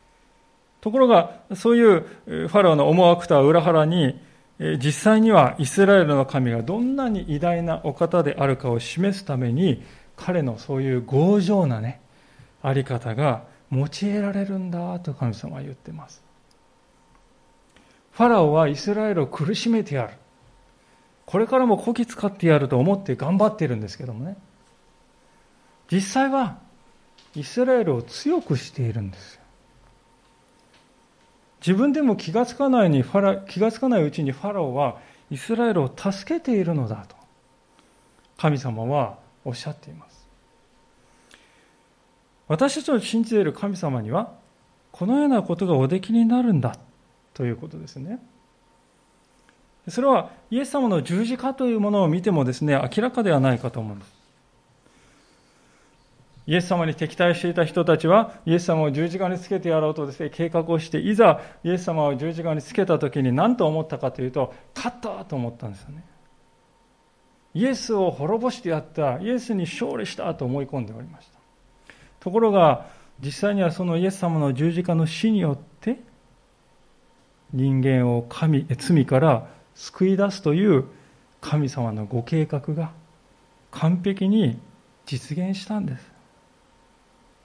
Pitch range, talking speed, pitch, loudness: 135-205 Hz, 290 characters per minute, 165 Hz, -22 LUFS